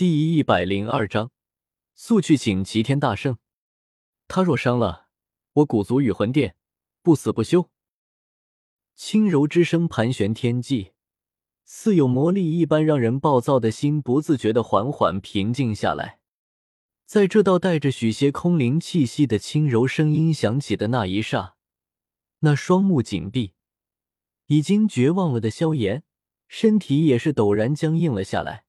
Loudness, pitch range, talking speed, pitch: -21 LUFS, 110-160 Hz, 215 characters per minute, 135 Hz